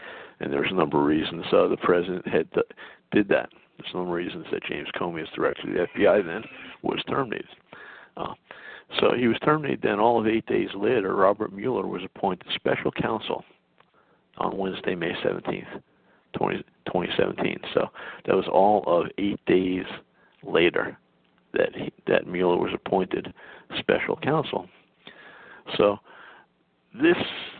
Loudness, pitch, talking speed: -25 LUFS, 115 Hz, 150 wpm